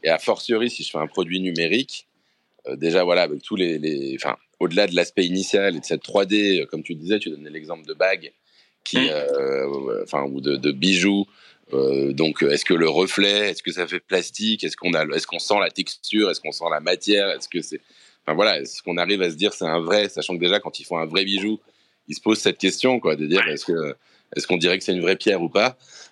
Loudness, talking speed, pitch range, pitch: -21 LUFS, 250 wpm, 80-105 Hz, 95 Hz